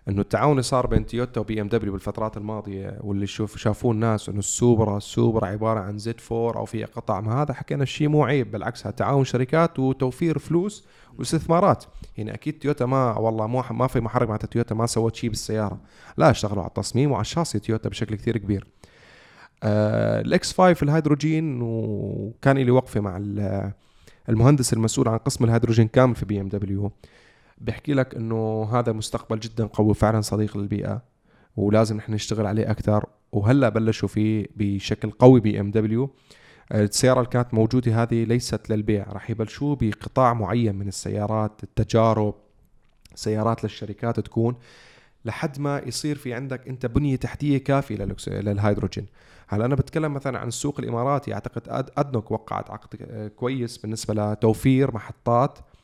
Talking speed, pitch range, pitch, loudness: 155 wpm, 105-130 Hz, 115 Hz, -23 LUFS